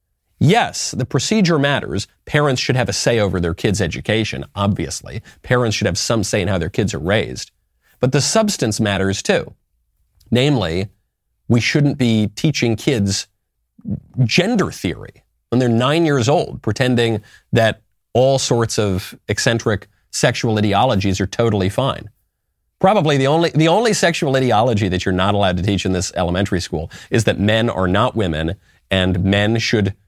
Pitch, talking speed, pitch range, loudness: 110 Hz, 160 wpm, 95-130 Hz, -17 LUFS